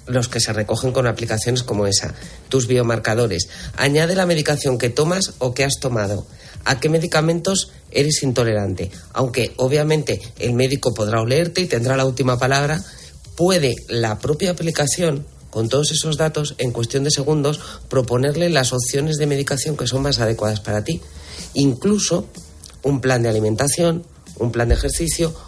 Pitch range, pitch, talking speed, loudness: 115-150 Hz, 130 Hz, 160 wpm, -19 LUFS